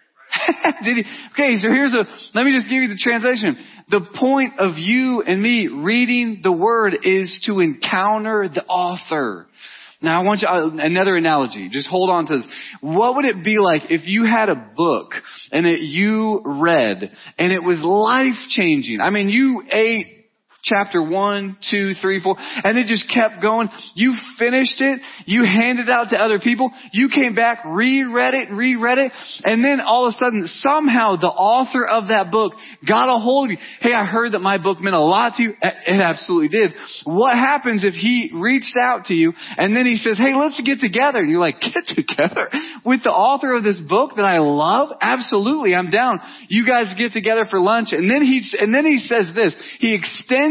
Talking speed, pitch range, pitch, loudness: 200 wpm, 195-255 Hz, 230 Hz, -17 LUFS